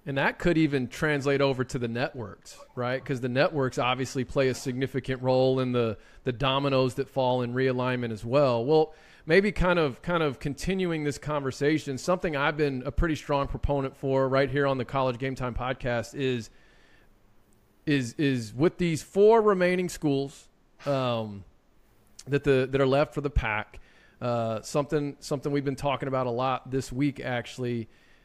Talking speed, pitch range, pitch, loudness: 175 wpm, 125-145 Hz, 135 Hz, -27 LUFS